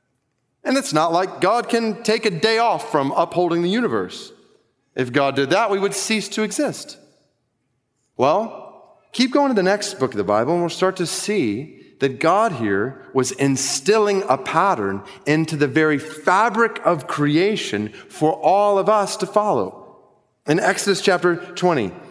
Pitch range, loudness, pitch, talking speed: 150-215 Hz, -19 LUFS, 185 Hz, 165 wpm